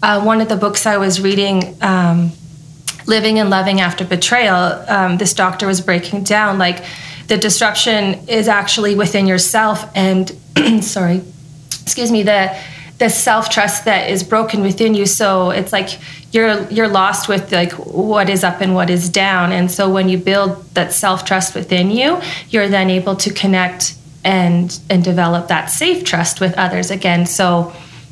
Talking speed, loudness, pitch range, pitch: 170 wpm, -14 LUFS, 180-205 Hz, 190 Hz